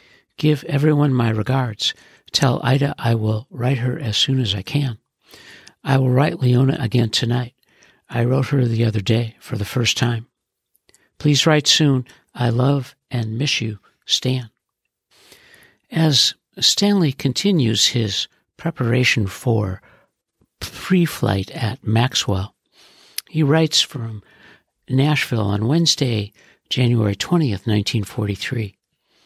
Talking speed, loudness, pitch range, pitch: 125 wpm, -19 LUFS, 115-145 Hz, 125 Hz